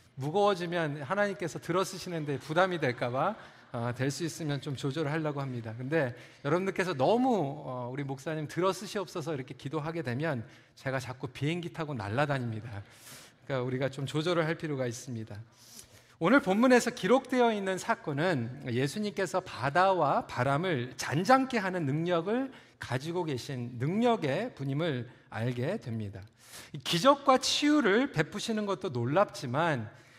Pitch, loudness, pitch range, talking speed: 150 Hz, -31 LUFS, 125-185 Hz, 340 characters per minute